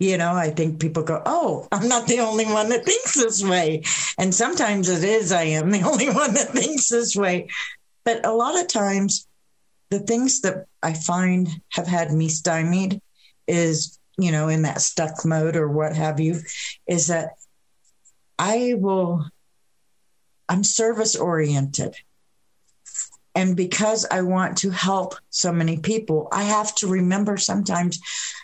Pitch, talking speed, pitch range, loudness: 185 Hz, 160 wpm, 165-210 Hz, -21 LUFS